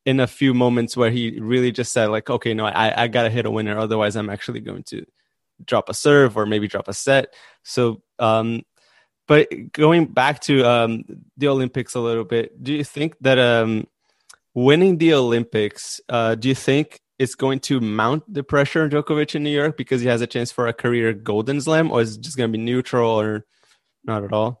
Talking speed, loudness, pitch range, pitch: 210 wpm, -20 LUFS, 115-140 Hz, 120 Hz